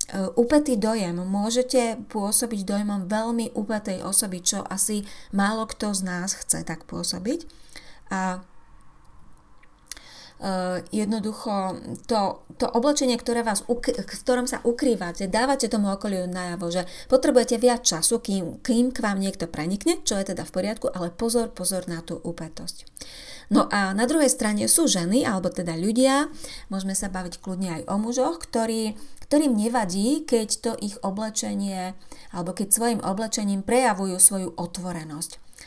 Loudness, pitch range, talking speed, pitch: -24 LUFS, 185-240 Hz, 140 wpm, 210 Hz